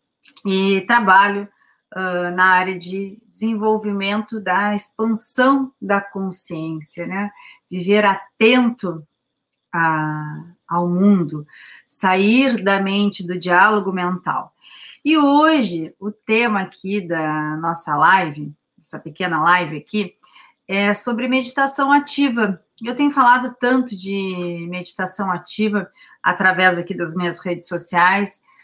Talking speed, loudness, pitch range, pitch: 110 wpm, -18 LUFS, 175-215 Hz, 195 Hz